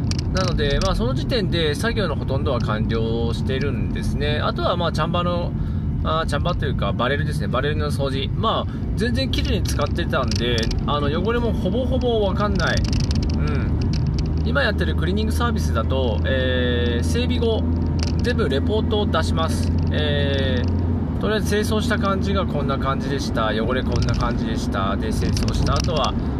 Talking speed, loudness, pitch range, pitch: 365 characters per minute, -21 LUFS, 80-95 Hz, 80 Hz